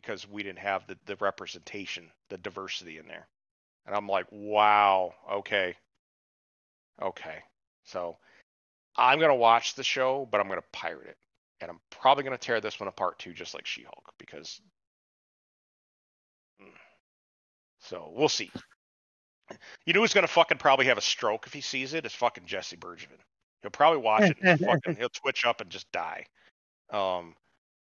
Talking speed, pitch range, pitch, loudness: 170 wpm, 95-140 Hz, 105 Hz, -27 LUFS